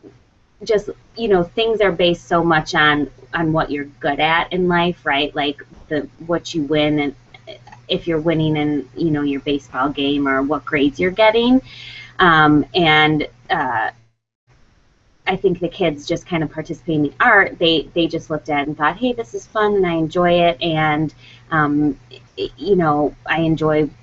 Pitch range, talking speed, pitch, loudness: 145-170 Hz, 185 wpm, 155 Hz, -18 LUFS